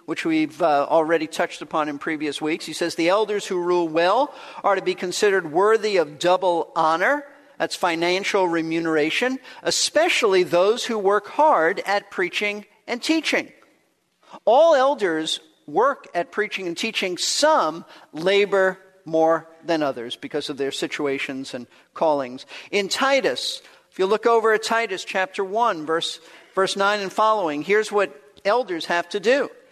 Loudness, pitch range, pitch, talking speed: -21 LUFS, 165-230 Hz, 190 Hz, 150 wpm